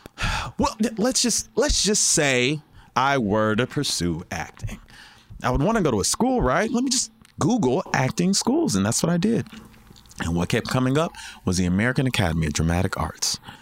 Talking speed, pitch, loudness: 190 wpm, 130 Hz, -22 LUFS